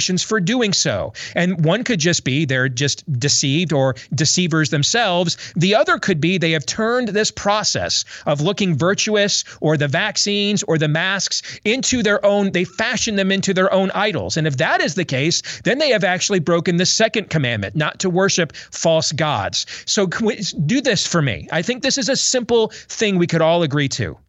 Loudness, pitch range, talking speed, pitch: -18 LUFS, 155-205 Hz, 195 wpm, 180 Hz